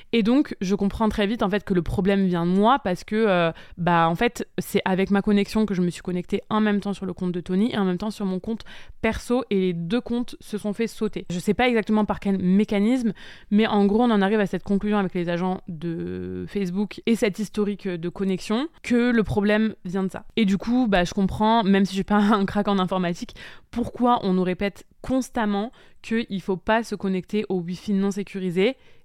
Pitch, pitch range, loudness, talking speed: 200 Hz, 185-220 Hz, -23 LUFS, 240 wpm